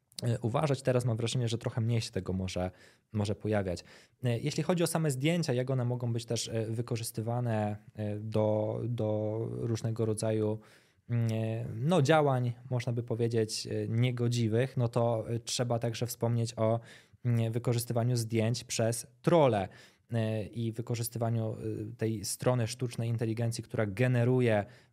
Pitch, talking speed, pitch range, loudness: 115 Hz, 125 wpm, 110-120 Hz, -32 LUFS